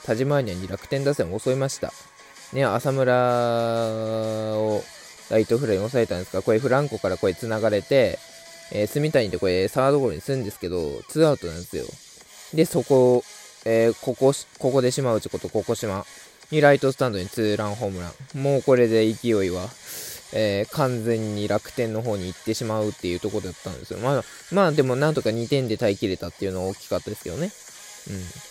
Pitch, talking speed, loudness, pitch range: 115 Hz, 400 characters per minute, -23 LUFS, 105-135 Hz